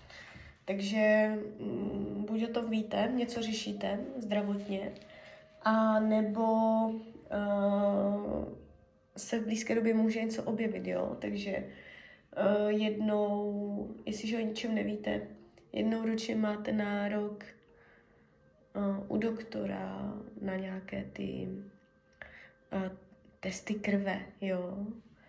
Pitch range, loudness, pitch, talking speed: 195-220 Hz, -34 LUFS, 210 Hz, 95 wpm